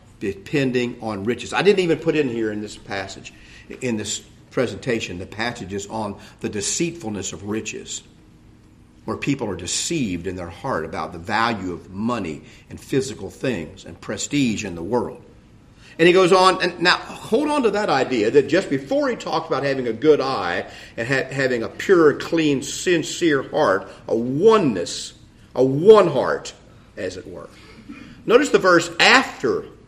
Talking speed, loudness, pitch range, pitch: 165 wpm, -20 LUFS, 105-175 Hz, 120 Hz